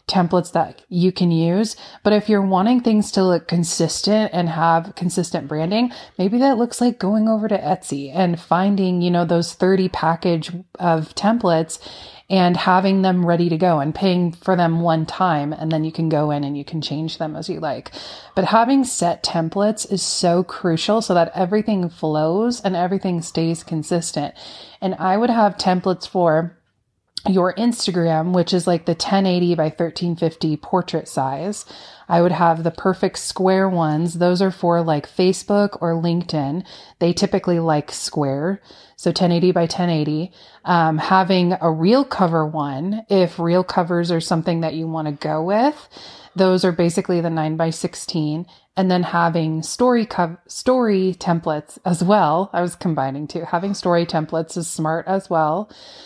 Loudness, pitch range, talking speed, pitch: -19 LUFS, 165-190 Hz, 170 wpm, 175 Hz